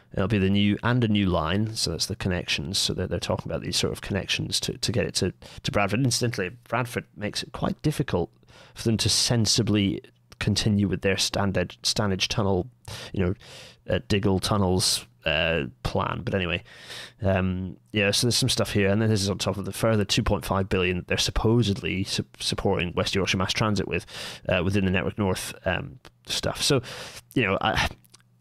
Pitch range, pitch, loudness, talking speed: 95-110 Hz, 100 Hz, -25 LUFS, 195 wpm